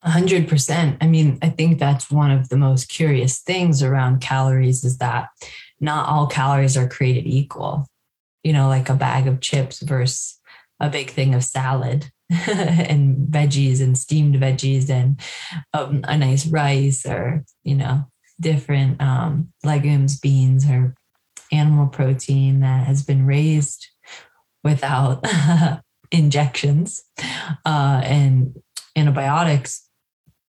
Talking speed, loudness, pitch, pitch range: 125 wpm, -19 LUFS, 140 Hz, 130-150 Hz